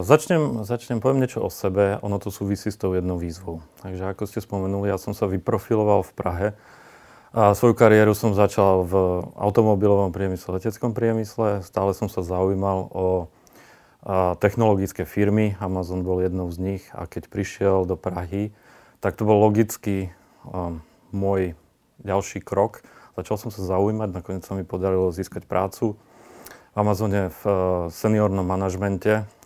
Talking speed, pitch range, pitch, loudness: 145 wpm, 95-105 Hz, 100 Hz, -23 LUFS